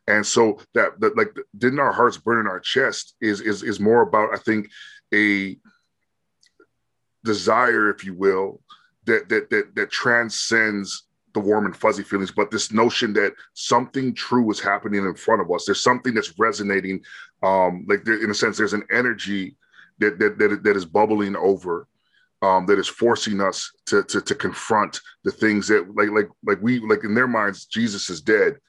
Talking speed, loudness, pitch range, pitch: 185 wpm, -21 LUFS, 100-115 Hz, 105 Hz